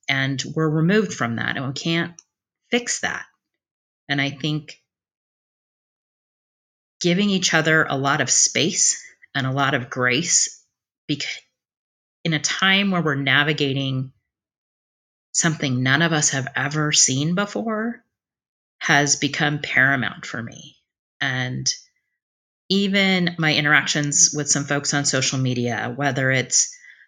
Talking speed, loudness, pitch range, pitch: 125 wpm, -20 LUFS, 135-170 Hz, 145 Hz